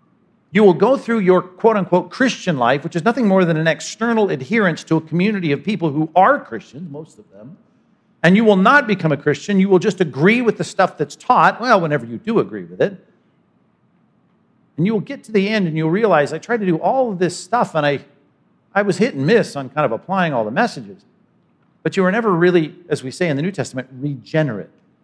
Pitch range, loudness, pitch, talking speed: 155-210 Hz, -17 LUFS, 180 Hz, 230 wpm